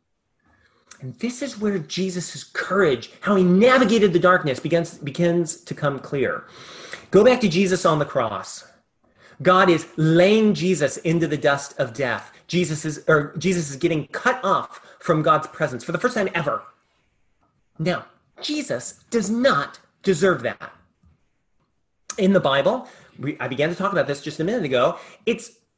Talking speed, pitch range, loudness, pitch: 160 wpm, 150-195 Hz, -21 LUFS, 175 Hz